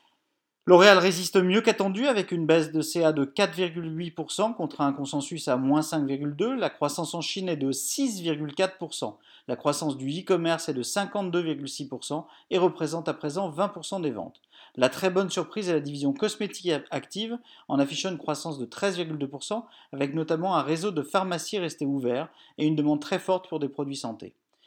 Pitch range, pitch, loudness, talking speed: 145-190 Hz, 165 Hz, -27 LUFS, 170 wpm